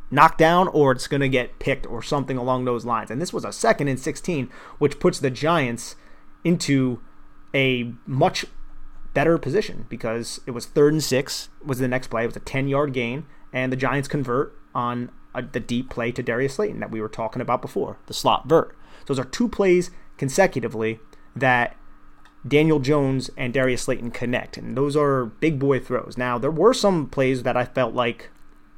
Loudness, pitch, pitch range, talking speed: -23 LUFS, 130 Hz, 120-145 Hz, 195 wpm